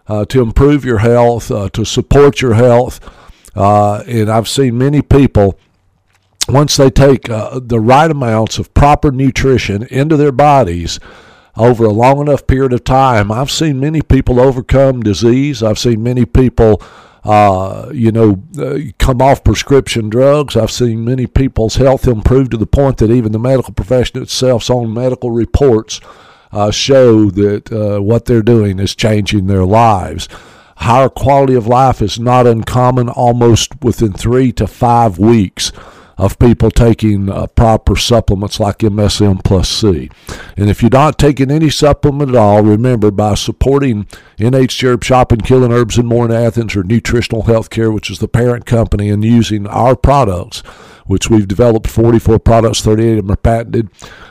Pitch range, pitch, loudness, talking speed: 105-130 Hz, 115 Hz, -11 LUFS, 165 wpm